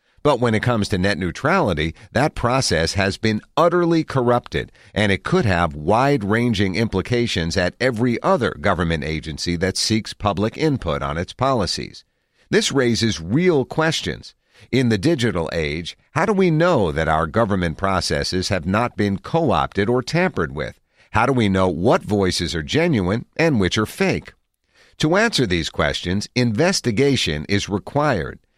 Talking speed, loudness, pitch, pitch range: 155 wpm, -20 LUFS, 110 Hz, 90-130 Hz